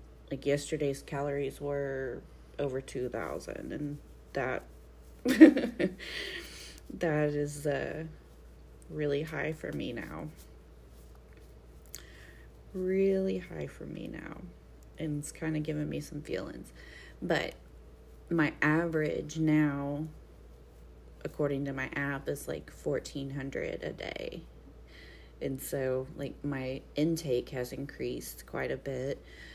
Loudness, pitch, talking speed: -33 LUFS, 140 Hz, 110 wpm